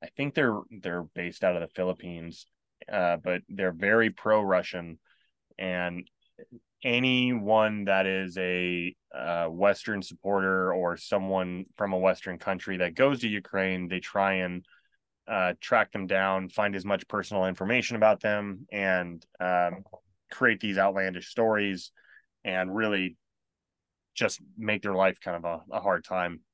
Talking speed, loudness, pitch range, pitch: 145 wpm, -28 LUFS, 90-105 Hz, 95 Hz